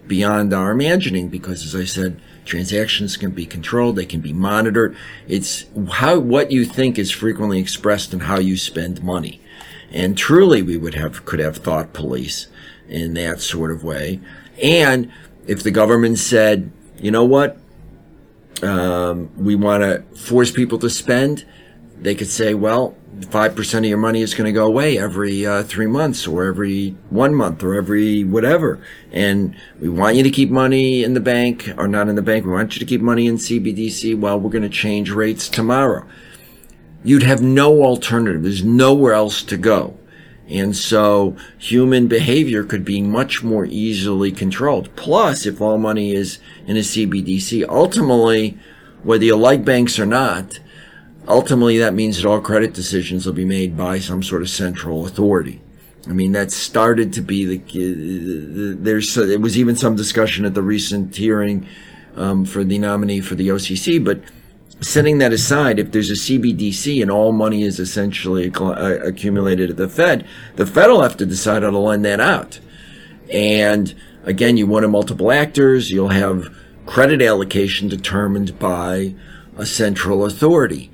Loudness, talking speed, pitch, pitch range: -17 LUFS, 170 wpm, 105 Hz, 95-115 Hz